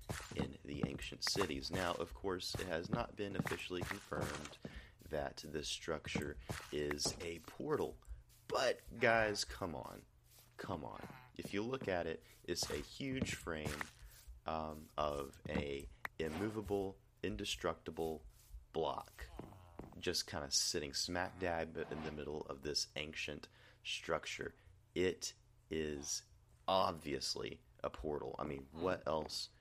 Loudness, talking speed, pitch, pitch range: -42 LUFS, 125 wpm, 80 Hz, 75-100 Hz